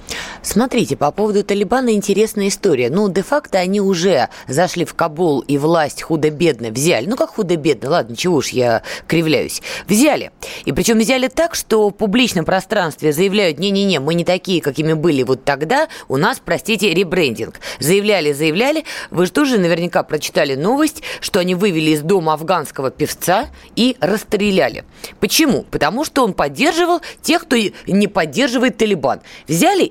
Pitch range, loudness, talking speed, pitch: 165-230 Hz, -16 LUFS, 155 wpm, 195 Hz